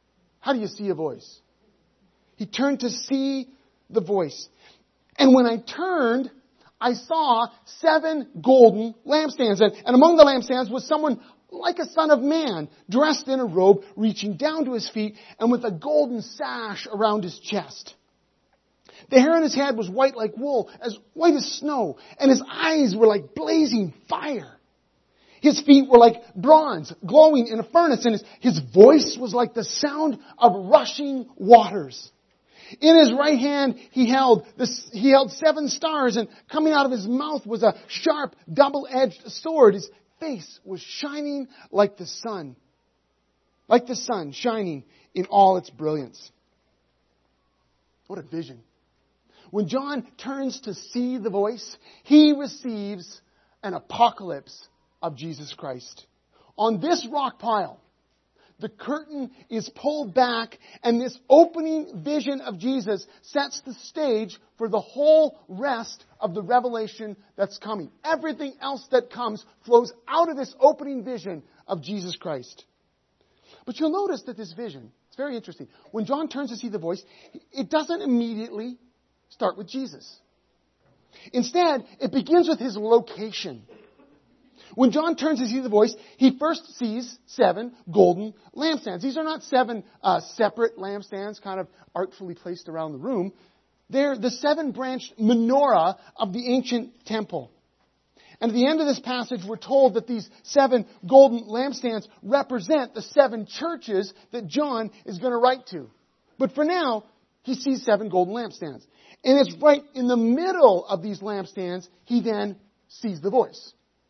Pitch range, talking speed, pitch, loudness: 210-275 Hz, 155 wpm, 240 Hz, -22 LUFS